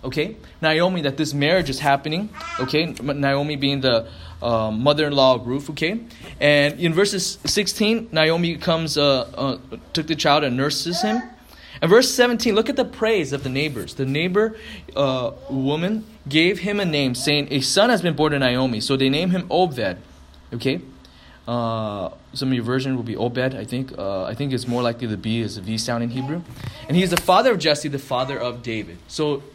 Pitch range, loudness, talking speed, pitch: 125-165 Hz, -21 LUFS, 205 wpm, 140 Hz